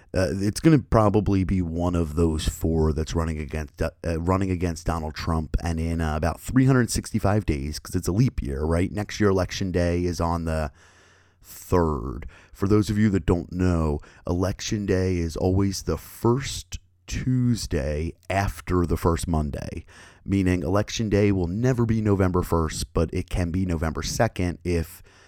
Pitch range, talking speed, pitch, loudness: 80-100 Hz, 170 wpm, 90 Hz, -25 LUFS